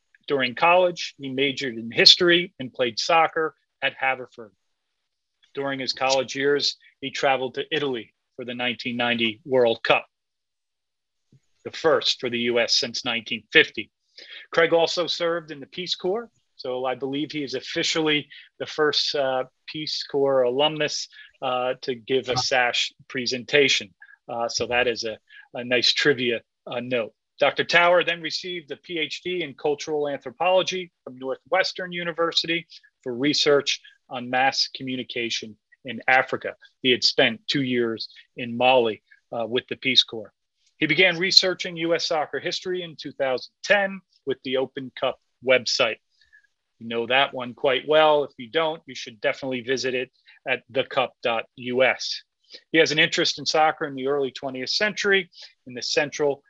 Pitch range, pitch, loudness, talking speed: 125-165 Hz, 140 Hz, -23 LUFS, 150 wpm